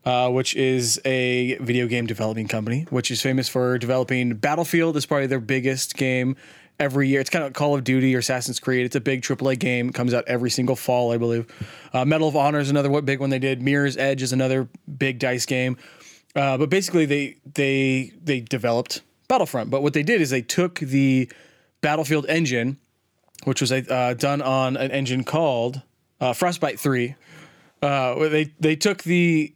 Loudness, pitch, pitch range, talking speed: -22 LUFS, 135 Hz, 125-150 Hz, 195 wpm